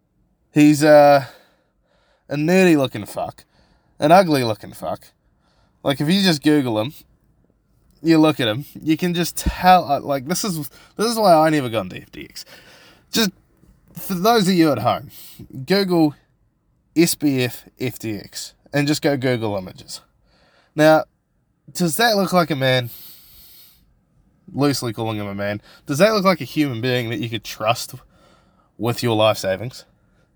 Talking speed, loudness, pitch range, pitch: 150 wpm, -18 LUFS, 120-170 Hz, 145 Hz